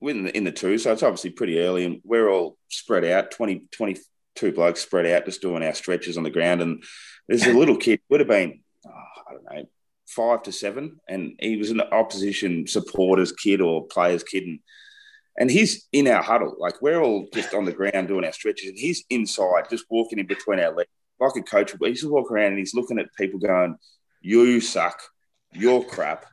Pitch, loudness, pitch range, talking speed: 105 Hz, -22 LUFS, 90-125 Hz, 210 wpm